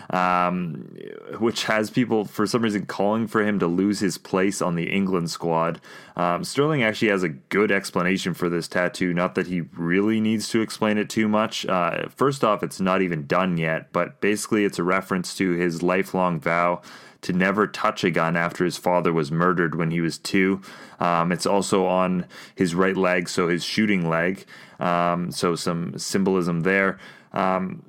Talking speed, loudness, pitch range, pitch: 185 wpm, -23 LUFS, 85-100 Hz, 90 Hz